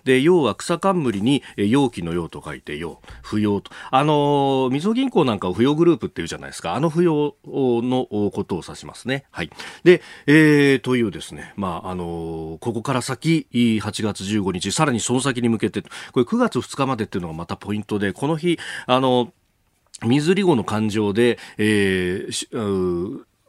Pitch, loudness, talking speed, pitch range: 120 Hz, -21 LUFS, 310 characters per minute, 100-145 Hz